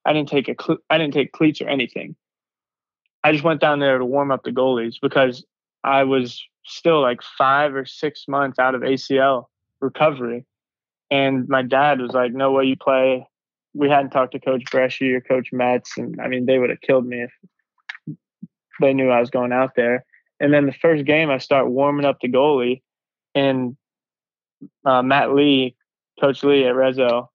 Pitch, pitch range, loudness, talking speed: 135 Hz, 125-140 Hz, -19 LUFS, 190 wpm